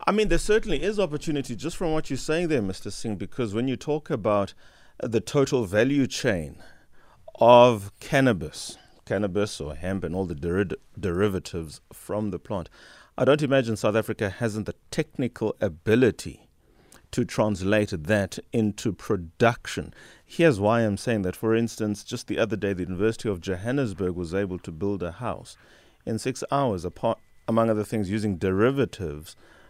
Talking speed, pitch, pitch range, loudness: 160 wpm, 110 Hz, 95-130 Hz, -26 LUFS